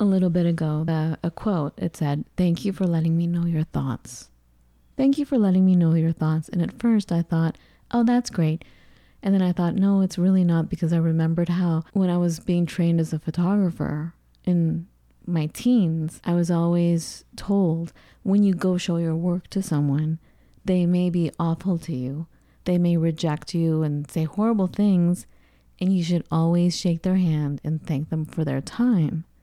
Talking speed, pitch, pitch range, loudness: 195 wpm, 170 Hz, 160-185 Hz, -23 LUFS